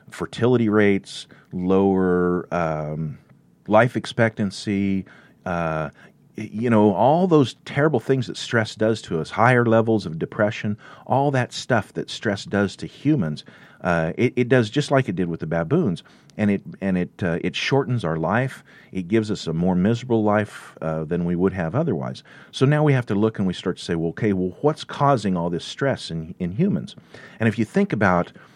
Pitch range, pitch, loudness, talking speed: 90-120 Hz, 105 Hz, -22 LUFS, 190 wpm